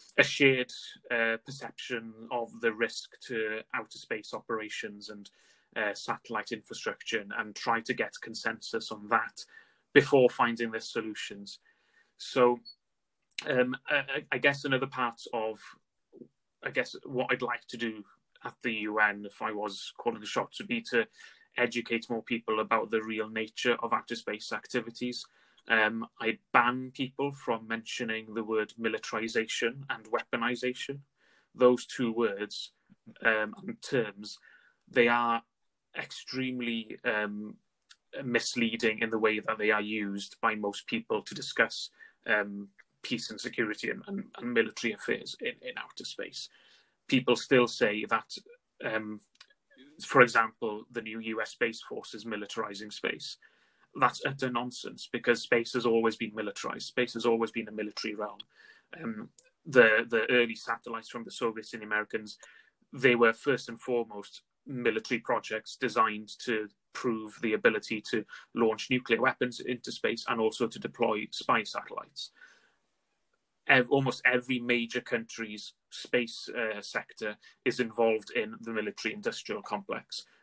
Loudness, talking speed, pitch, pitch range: -31 LUFS, 145 wpm, 115 Hz, 110-125 Hz